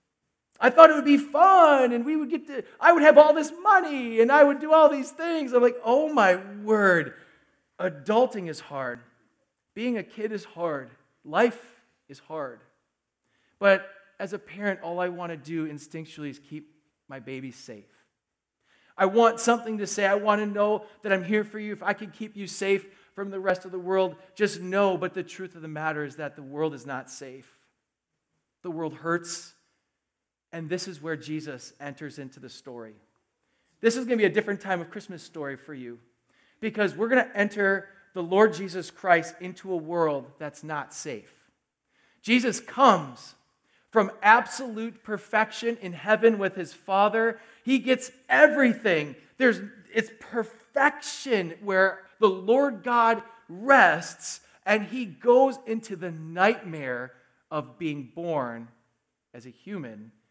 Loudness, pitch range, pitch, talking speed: -24 LUFS, 160-230 Hz, 195 Hz, 170 wpm